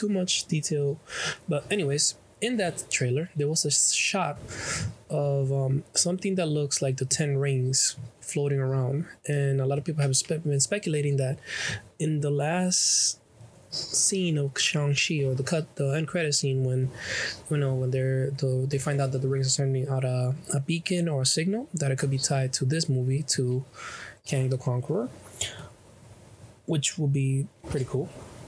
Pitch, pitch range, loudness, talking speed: 140 Hz, 130-155 Hz, -27 LUFS, 175 wpm